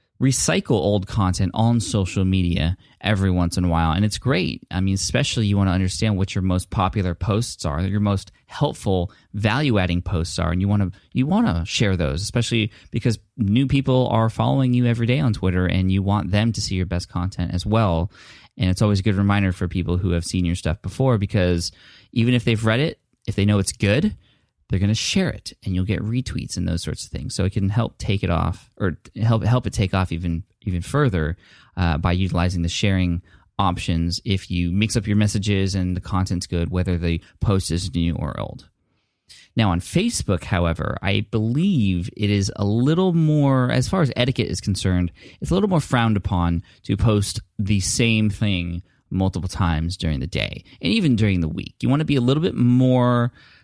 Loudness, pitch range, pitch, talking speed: -21 LUFS, 90-115 Hz, 100 Hz, 210 wpm